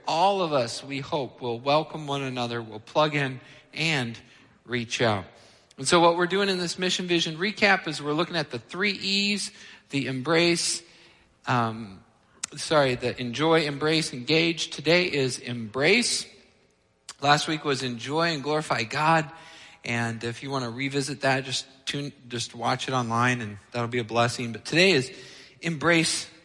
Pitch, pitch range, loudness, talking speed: 140 Hz, 120-165 Hz, -25 LUFS, 165 wpm